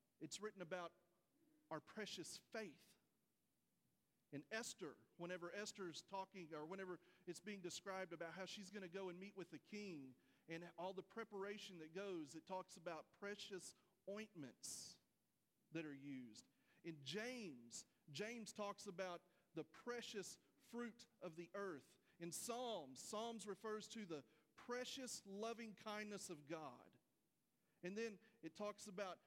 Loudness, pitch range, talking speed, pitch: -54 LUFS, 170-215 Hz, 140 wpm, 190 Hz